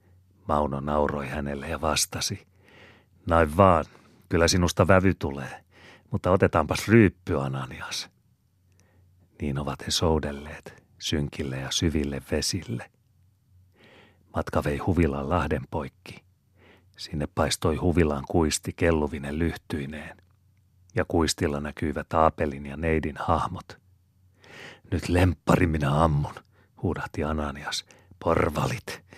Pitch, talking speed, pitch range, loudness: 85 Hz, 100 wpm, 75-95 Hz, -26 LUFS